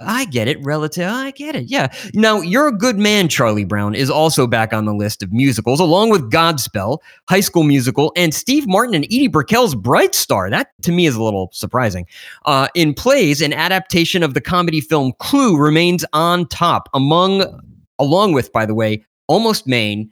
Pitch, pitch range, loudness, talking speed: 155 Hz, 125-185 Hz, -15 LUFS, 195 wpm